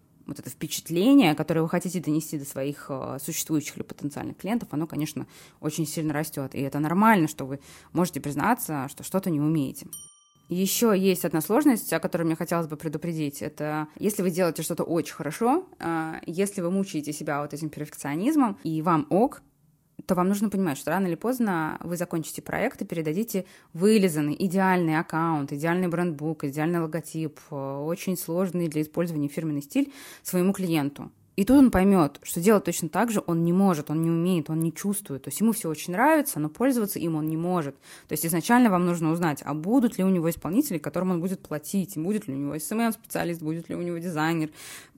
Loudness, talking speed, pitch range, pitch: -26 LUFS, 190 wpm, 155-190 Hz, 170 Hz